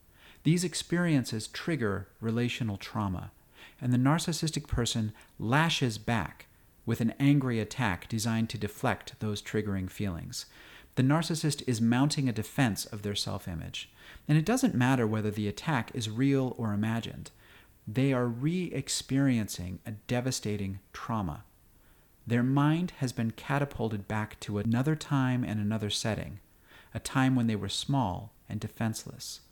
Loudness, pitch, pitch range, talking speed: -31 LUFS, 115 Hz, 105-135 Hz, 140 wpm